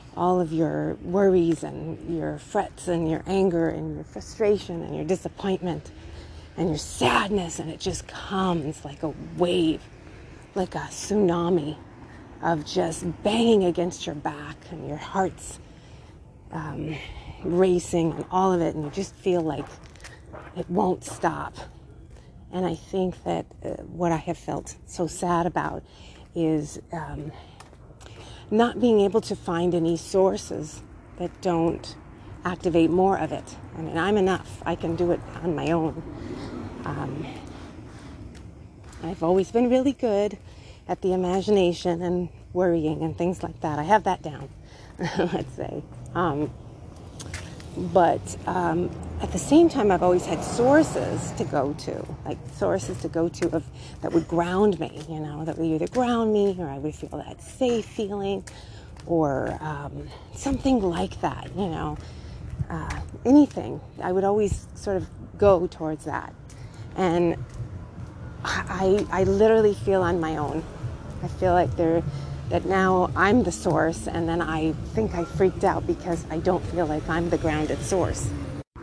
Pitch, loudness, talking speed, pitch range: 170 Hz, -25 LUFS, 150 wpm, 150-185 Hz